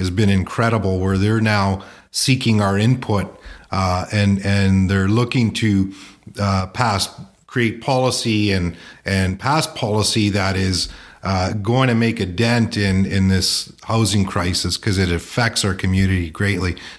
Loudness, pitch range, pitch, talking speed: -18 LUFS, 95-115 Hz, 100 Hz, 150 wpm